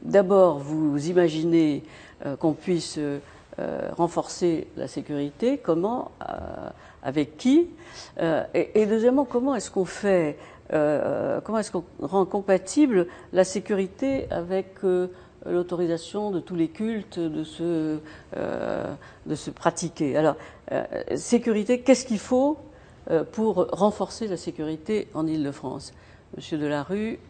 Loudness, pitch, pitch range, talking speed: -25 LUFS, 180 Hz, 155-215 Hz, 125 wpm